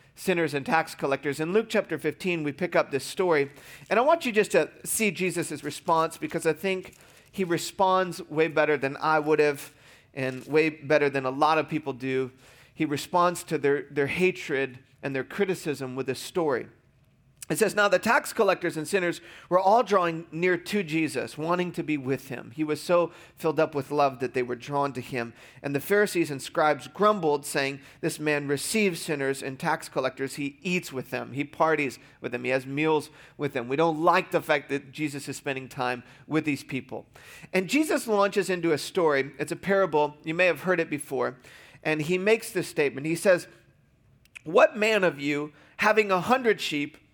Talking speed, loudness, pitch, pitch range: 200 wpm, -26 LUFS, 155 Hz, 140-180 Hz